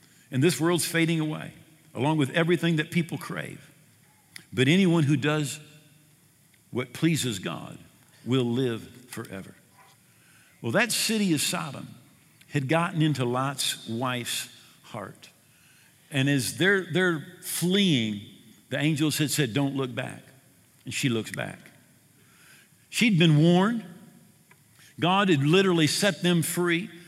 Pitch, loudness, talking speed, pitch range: 155 Hz, -25 LUFS, 125 wpm, 135-170 Hz